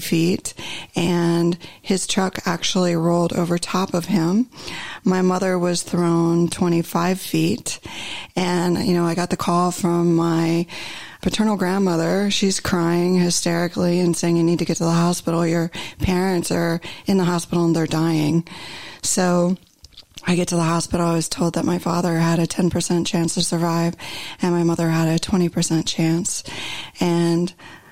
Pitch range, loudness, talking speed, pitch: 170-180 Hz, -20 LUFS, 160 wpm, 175 Hz